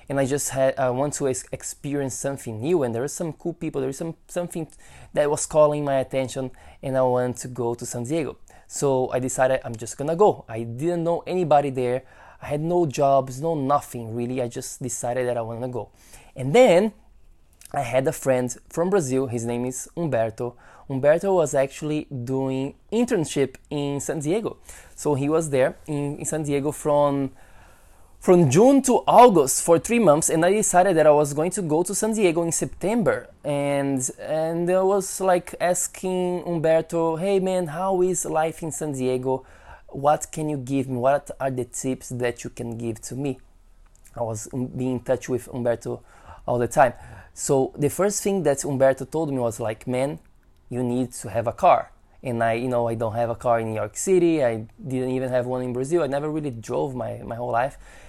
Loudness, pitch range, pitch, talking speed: -23 LUFS, 125-160 Hz, 135 Hz, 200 wpm